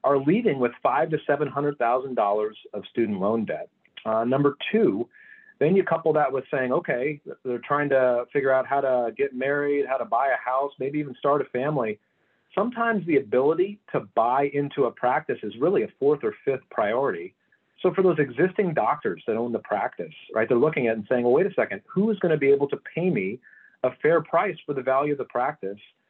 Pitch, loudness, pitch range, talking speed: 145 Hz, -24 LUFS, 130-200 Hz, 215 wpm